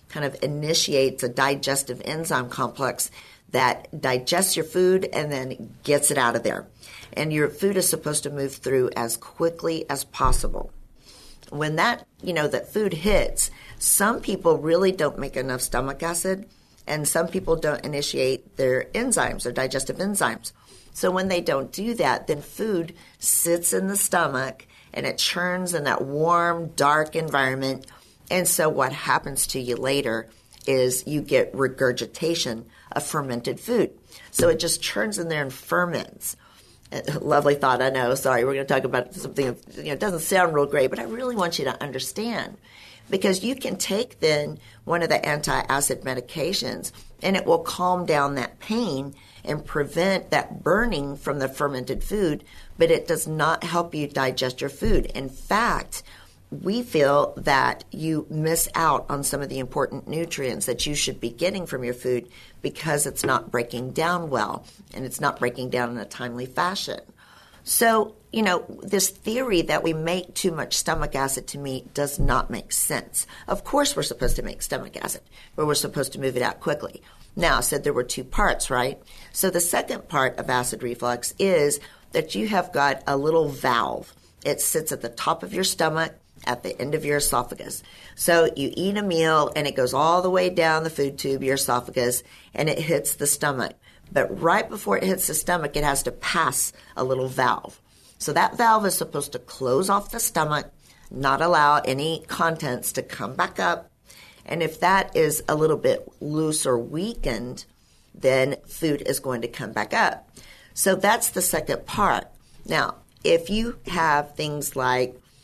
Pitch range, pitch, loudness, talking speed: 130-175 Hz, 150 Hz, -24 LUFS, 180 wpm